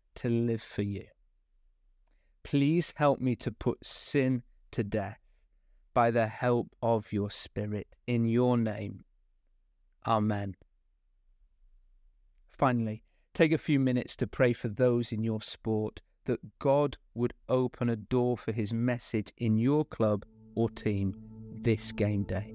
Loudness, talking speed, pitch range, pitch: -31 LUFS, 135 wpm, 100-125 Hz, 110 Hz